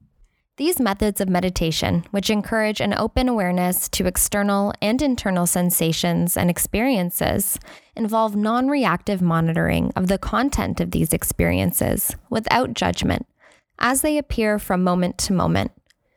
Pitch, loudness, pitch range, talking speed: 200 Hz, -21 LUFS, 175-225 Hz, 130 wpm